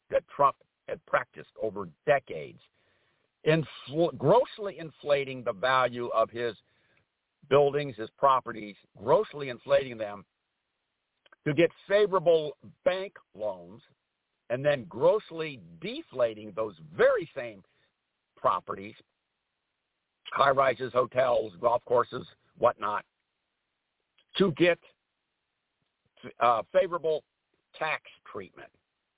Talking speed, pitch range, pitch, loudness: 90 wpm, 125-185 Hz, 150 Hz, -28 LUFS